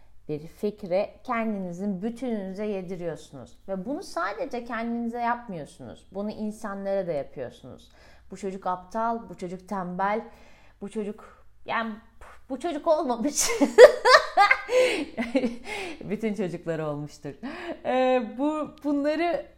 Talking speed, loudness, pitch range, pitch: 100 wpm, -25 LUFS, 195-285 Hz, 225 Hz